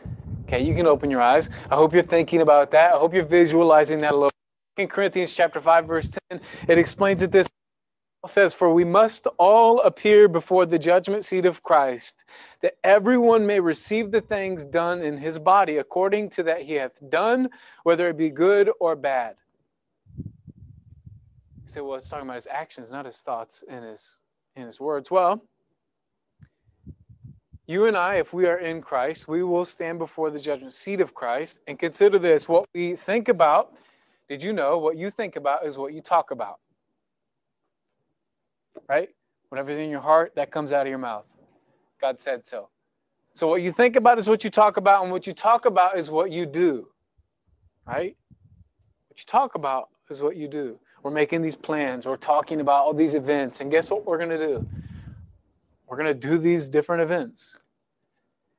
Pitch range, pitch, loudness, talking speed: 145-190 Hz, 165 Hz, -21 LUFS, 185 wpm